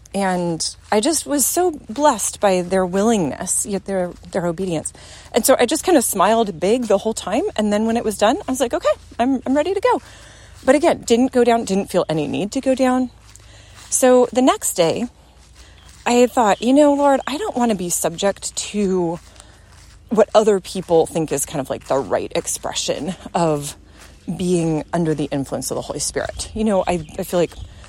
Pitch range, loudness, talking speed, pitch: 170-250 Hz, -19 LUFS, 200 wpm, 205 Hz